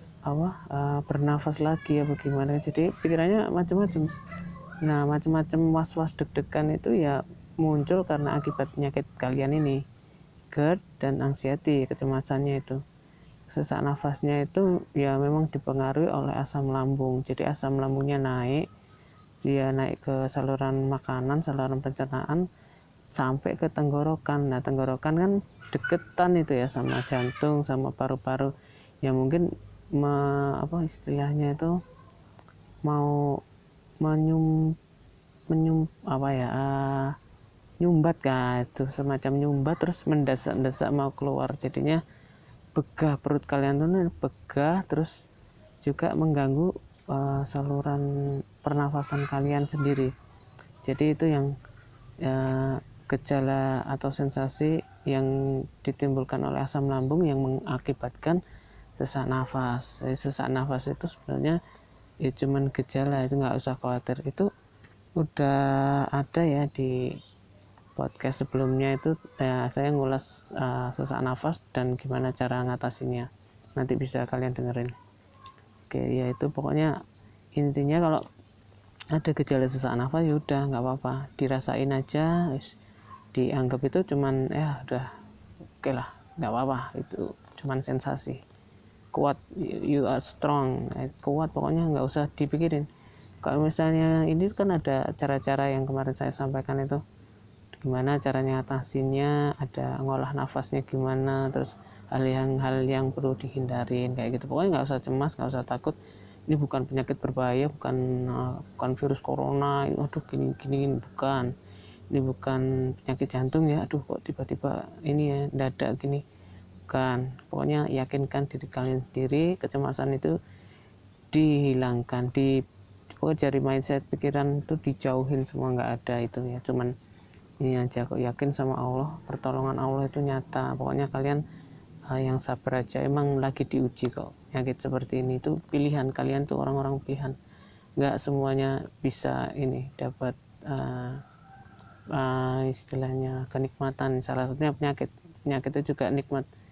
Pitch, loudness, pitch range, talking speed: 135 Hz, -28 LUFS, 130-145 Hz, 125 wpm